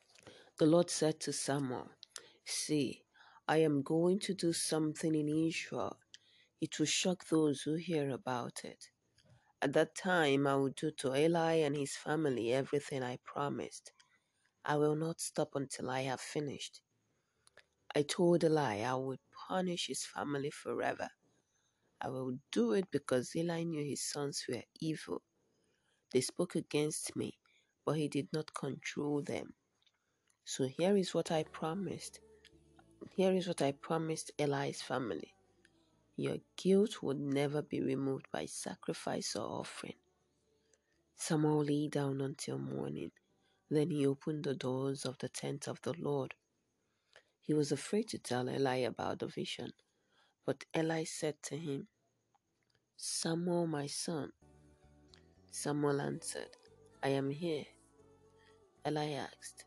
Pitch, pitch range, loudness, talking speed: 150 Hz, 135-160 Hz, -37 LUFS, 140 wpm